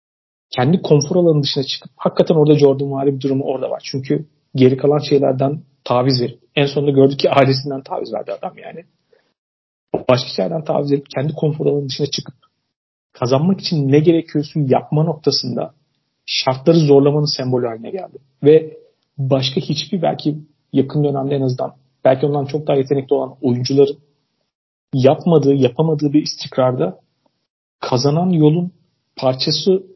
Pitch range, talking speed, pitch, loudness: 135-155 Hz, 140 wpm, 145 Hz, -17 LUFS